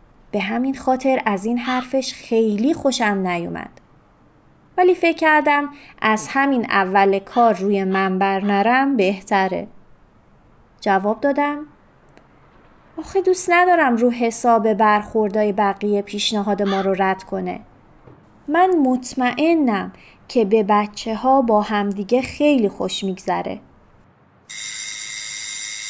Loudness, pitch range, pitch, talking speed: -19 LUFS, 195-265 Hz, 220 Hz, 105 wpm